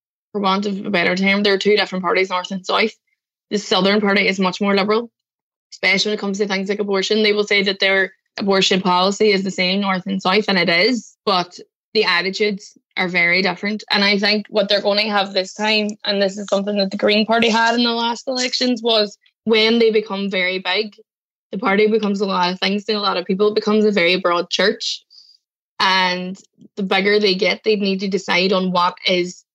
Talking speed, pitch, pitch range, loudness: 225 wpm, 200 Hz, 190-215 Hz, -17 LUFS